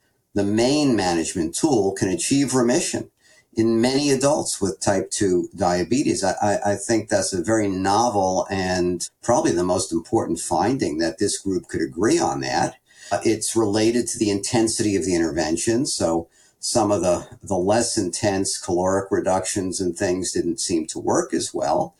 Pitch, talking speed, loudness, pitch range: 105 Hz, 160 wpm, -22 LUFS, 95-120 Hz